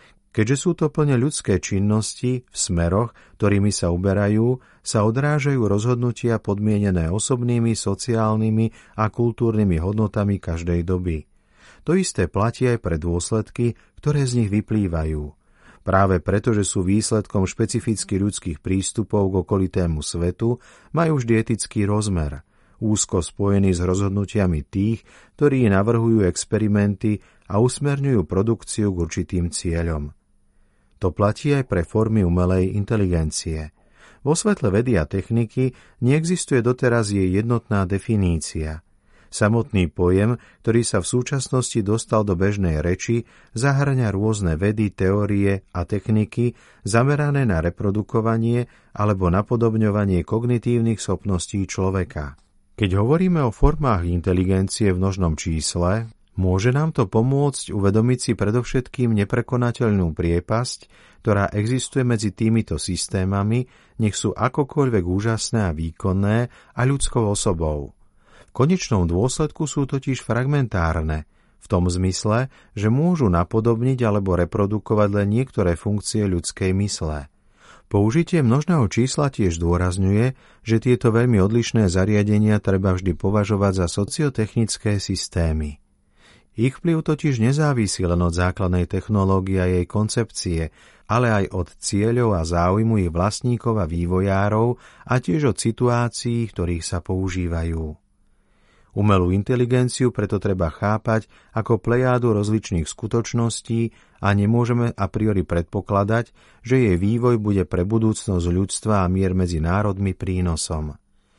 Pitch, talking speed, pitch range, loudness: 105 Hz, 120 wpm, 95-120 Hz, -21 LUFS